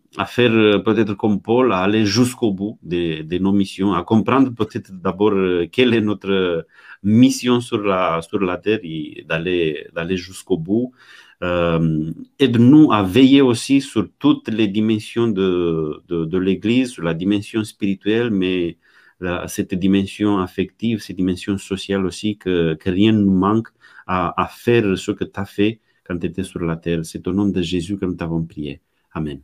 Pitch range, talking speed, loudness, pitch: 90-110 Hz, 180 wpm, -18 LUFS, 100 Hz